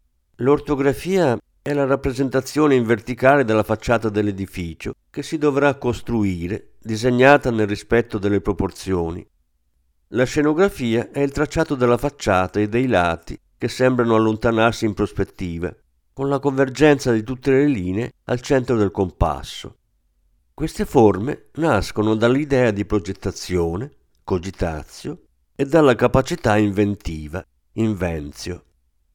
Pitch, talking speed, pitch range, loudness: 110 Hz, 115 wpm, 95-135 Hz, -20 LUFS